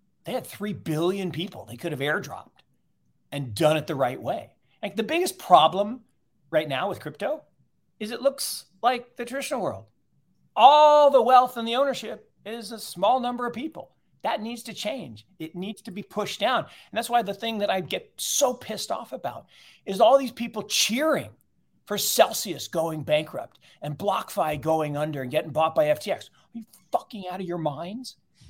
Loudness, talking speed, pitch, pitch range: -25 LUFS, 185 wpm, 210 Hz, 160-240 Hz